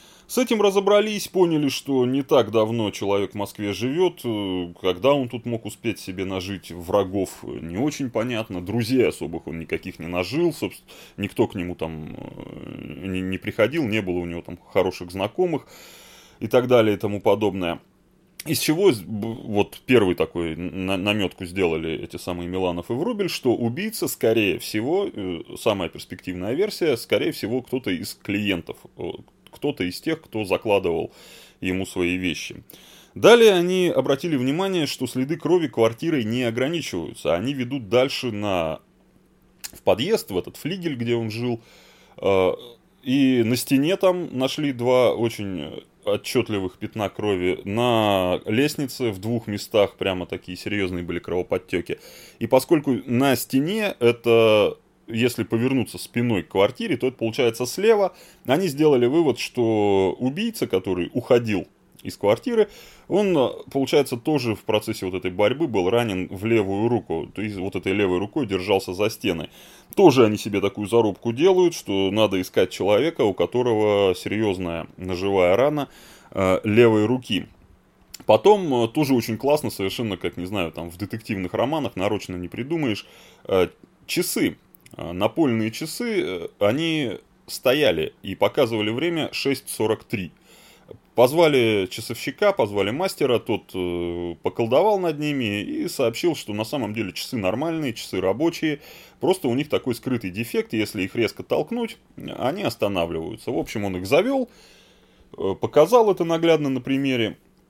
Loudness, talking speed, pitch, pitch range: -23 LUFS, 140 wpm, 115 Hz, 95-135 Hz